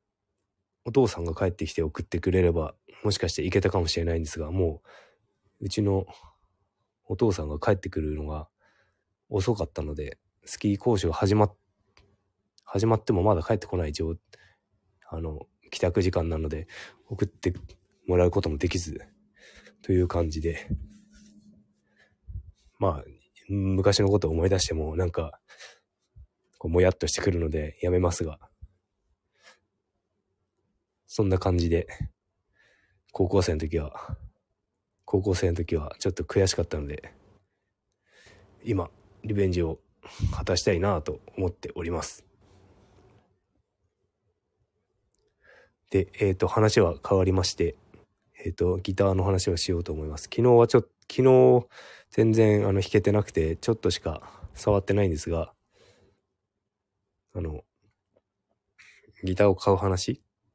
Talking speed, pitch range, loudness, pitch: 260 characters per minute, 85-100 Hz, -26 LUFS, 95 Hz